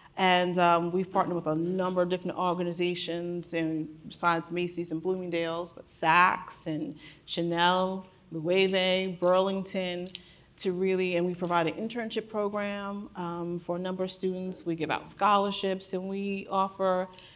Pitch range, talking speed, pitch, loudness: 170-190 Hz, 145 wpm, 180 Hz, -29 LUFS